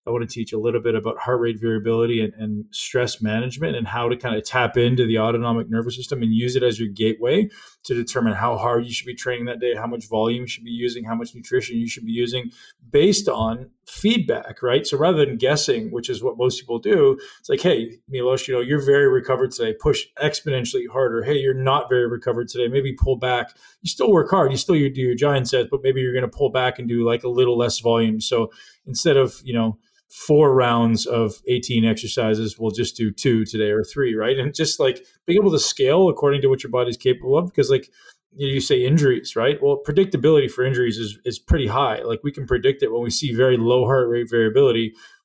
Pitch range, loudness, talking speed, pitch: 115-140 Hz, -20 LUFS, 230 wpm, 125 Hz